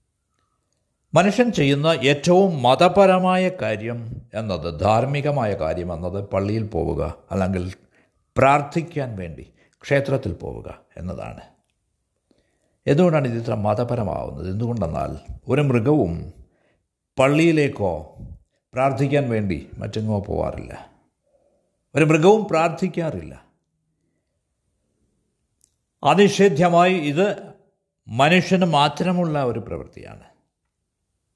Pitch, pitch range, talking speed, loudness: 130 Hz, 100-165 Hz, 70 wpm, -20 LUFS